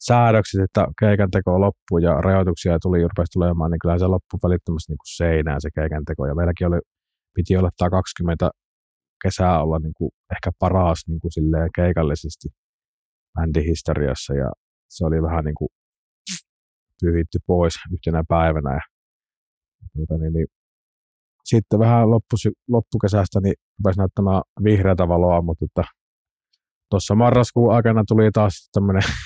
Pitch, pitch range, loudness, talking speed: 90 Hz, 80-100 Hz, -20 LUFS, 125 wpm